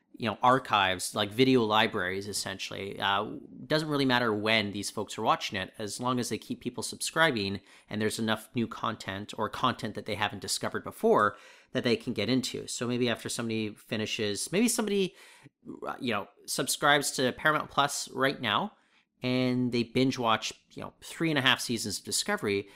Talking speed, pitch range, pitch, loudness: 180 wpm, 105-130 Hz, 115 Hz, -29 LUFS